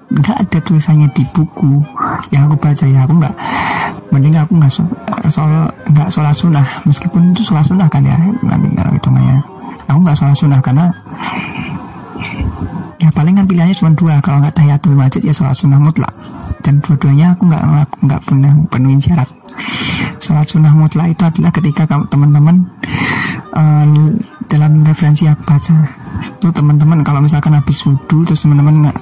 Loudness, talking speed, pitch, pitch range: -11 LUFS, 165 wpm, 155 Hz, 145-165 Hz